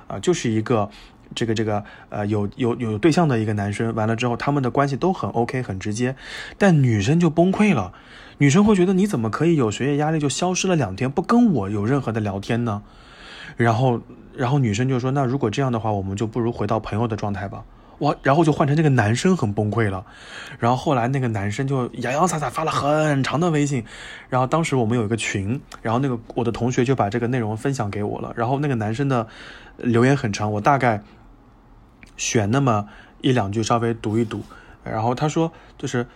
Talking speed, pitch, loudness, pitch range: 325 characters per minute, 120 Hz, -21 LUFS, 110-140 Hz